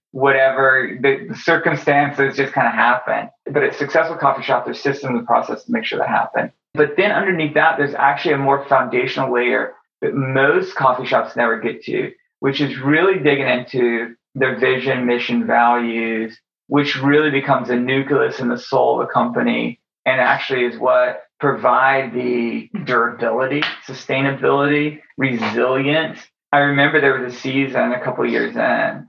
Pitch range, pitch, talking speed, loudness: 125-145 Hz, 135 Hz, 165 wpm, -17 LUFS